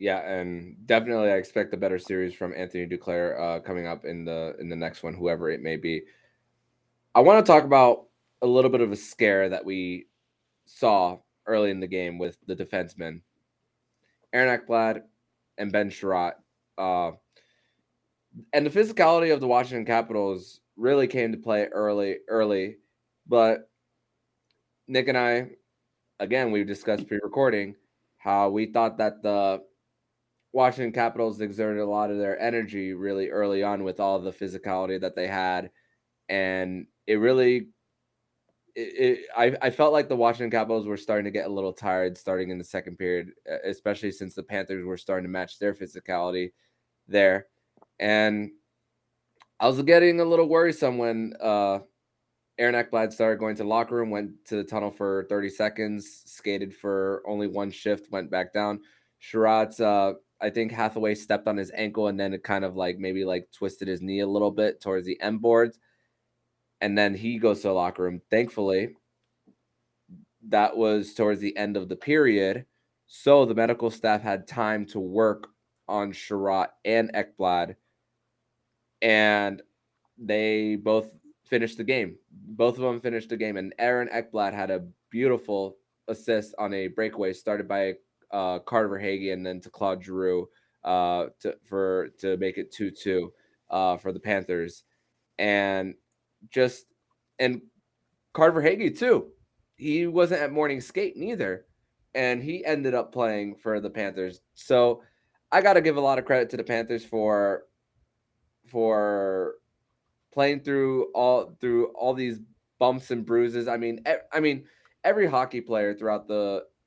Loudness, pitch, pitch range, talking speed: -26 LUFS, 105 Hz, 95-120 Hz, 165 wpm